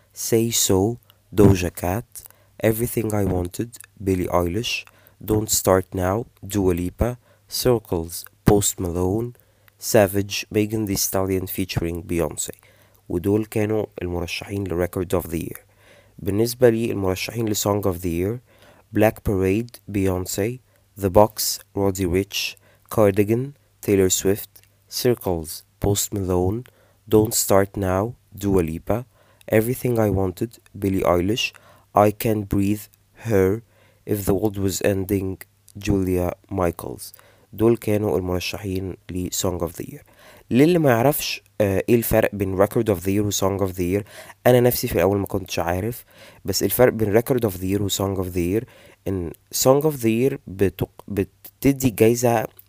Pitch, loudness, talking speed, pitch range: 100 Hz, -22 LUFS, 135 wpm, 95-110 Hz